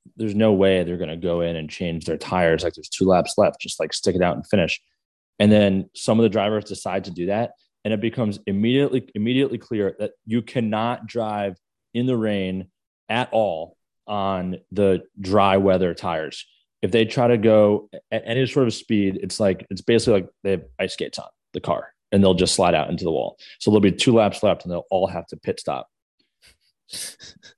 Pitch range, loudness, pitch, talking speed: 95-115 Hz, -22 LUFS, 105 Hz, 210 wpm